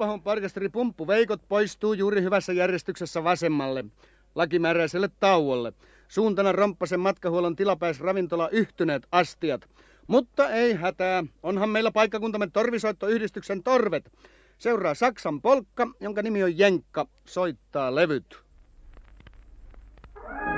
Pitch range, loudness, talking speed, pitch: 170-215 Hz, -25 LUFS, 95 wpm, 190 Hz